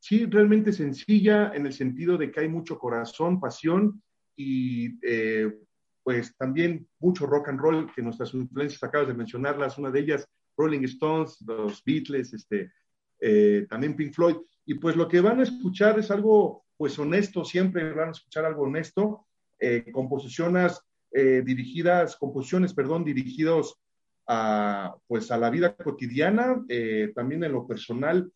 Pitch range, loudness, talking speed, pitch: 130-175 Hz, -26 LUFS, 155 wpm, 150 Hz